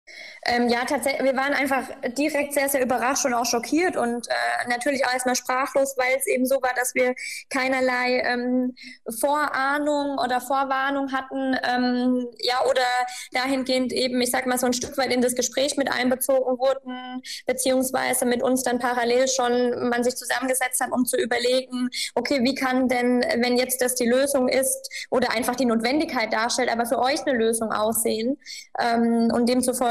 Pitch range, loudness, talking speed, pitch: 245-270 Hz, -23 LUFS, 175 wpm, 255 Hz